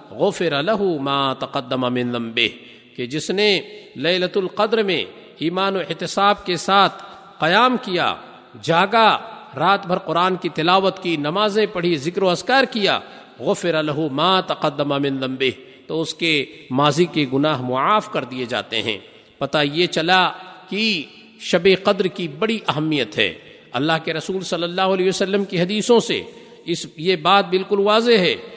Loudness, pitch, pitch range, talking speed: -19 LUFS, 180 Hz, 150-200 Hz, 160 wpm